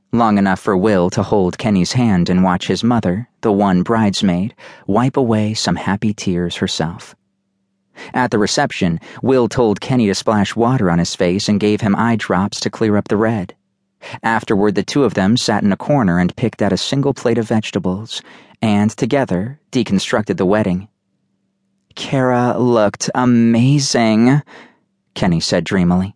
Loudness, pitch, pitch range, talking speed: -16 LUFS, 105 Hz, 95-120 Hz, 165 wpm